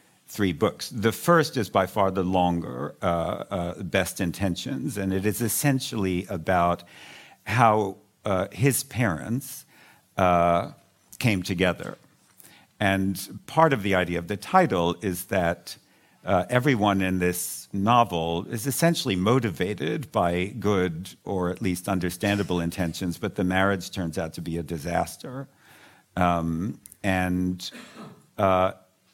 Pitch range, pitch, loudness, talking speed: 90-110 Hz, 95 Hz, -25 LUFS, 130 wpm